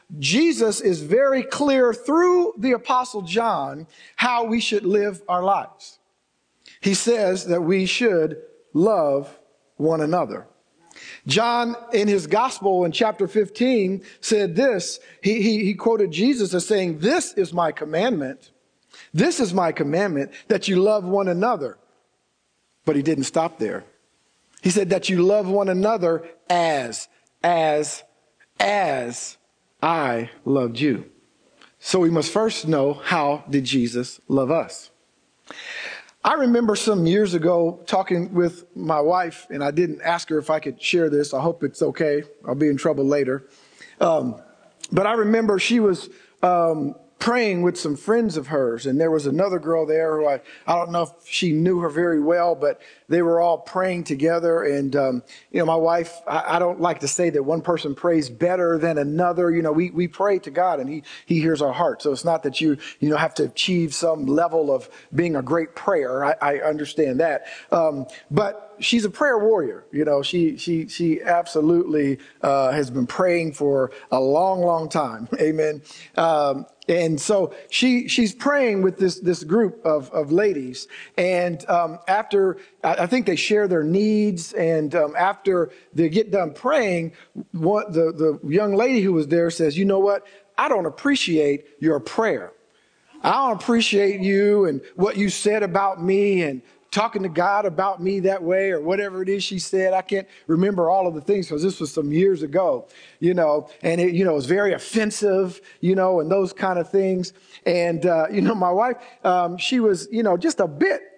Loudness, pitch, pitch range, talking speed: -21 LUFS, 175 Hz, 155-200 Hz, 180 wpm